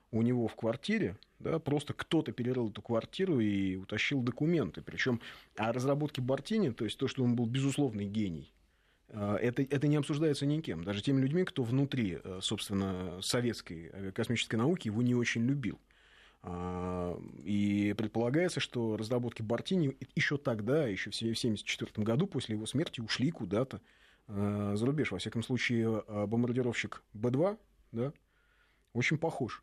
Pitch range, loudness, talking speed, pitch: 105-140 Hz, -34 LUFS, 140 wpm, 120 Hz